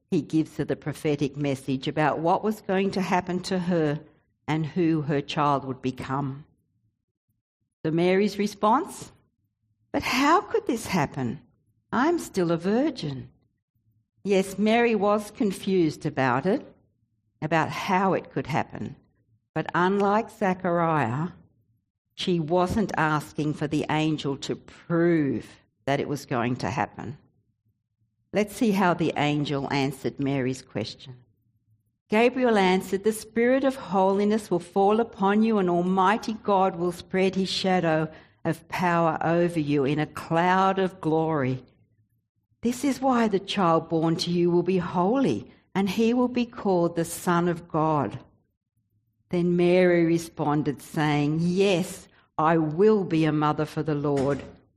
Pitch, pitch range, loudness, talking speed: 160 Hz, 135-190 Hz, -25 LUFS, 140 wpm